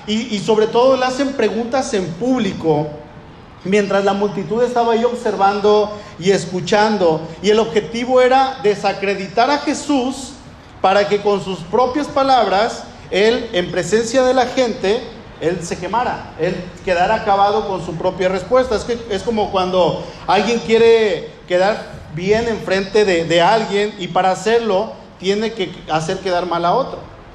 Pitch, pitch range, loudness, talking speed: 205 Hz, 185-230 Hz, -17 LUFS, 150 wpm